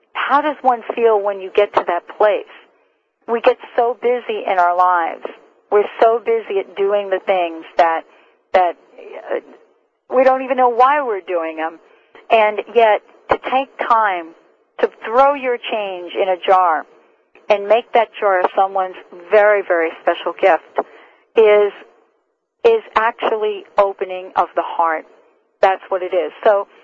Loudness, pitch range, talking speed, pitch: -17 LUFS, 190-260 Hz, 150 wpm, 215 Hz